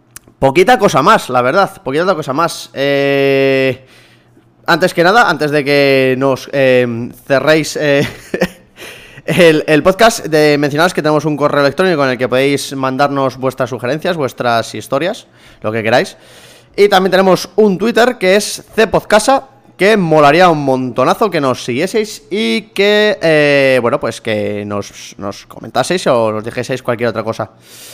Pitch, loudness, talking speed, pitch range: 145 Hz, -12 LUFS, 150 wpm, 130-180 Hz